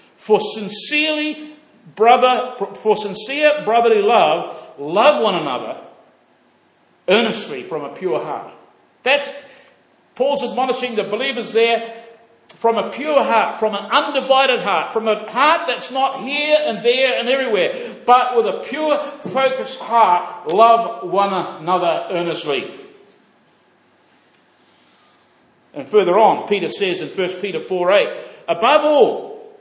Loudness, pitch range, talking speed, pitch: -17 LUFS, 215-295 Hz, 125 wpm, 250 Hz